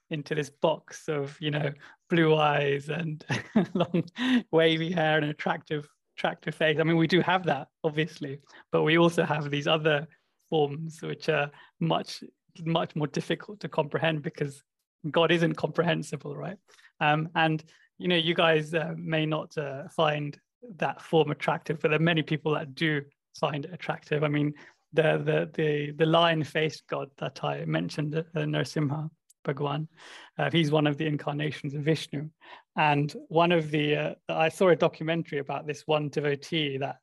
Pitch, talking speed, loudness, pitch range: 155 Hz, 170 wpm, -28 LUFS, 150-165 Hz